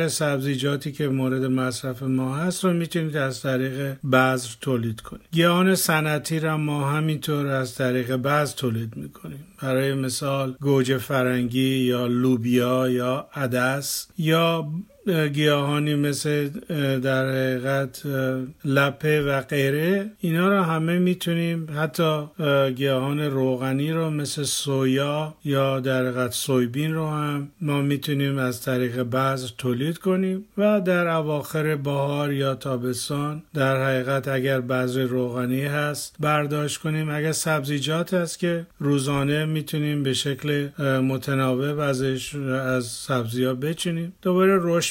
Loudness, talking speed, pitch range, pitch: -24 LUFS, 120 wpm, 130-155 Hz, 140 Hz